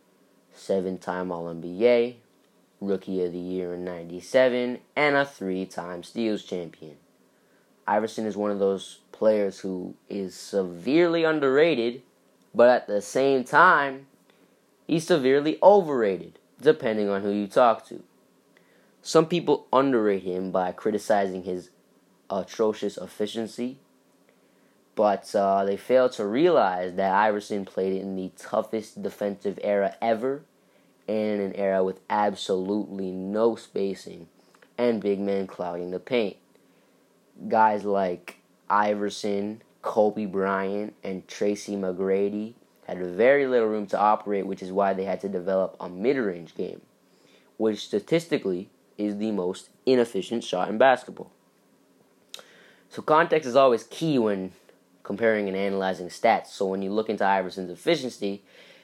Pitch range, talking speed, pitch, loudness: 95-115 Hz, 125 wpm, 100 Hz, -25 LUFS